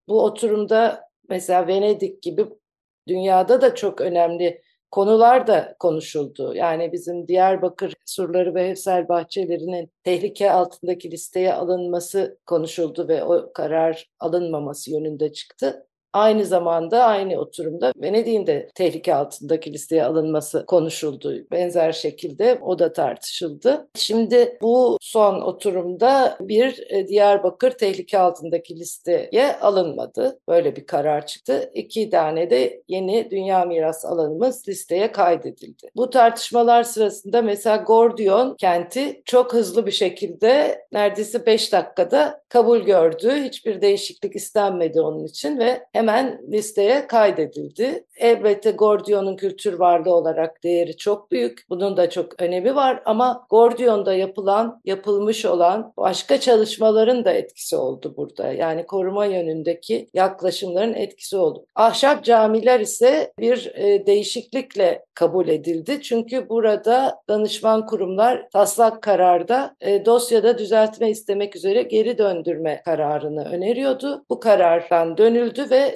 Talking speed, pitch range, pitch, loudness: 120 wpm, 175-235 Hz, 200 Hz, -20 LUFS